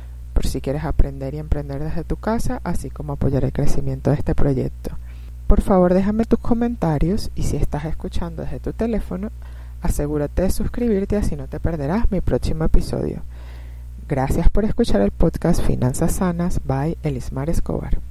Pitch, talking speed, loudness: 145 Hz, 160 wpm, -22 LUFS